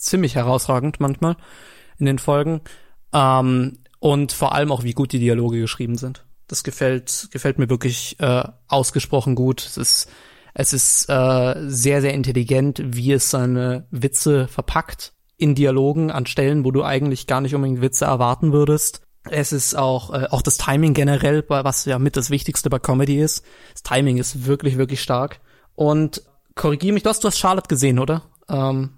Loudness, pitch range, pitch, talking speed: -19 LUFS, 130-145 Hz, 135 Hz, 180 wpm